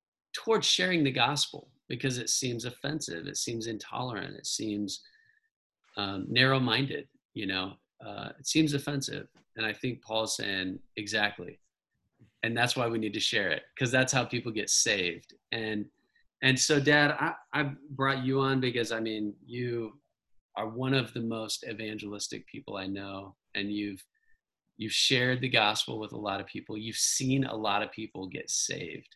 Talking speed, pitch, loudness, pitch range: 170 wpm, 120 Hz, -30 LUFS, 105-135 Hz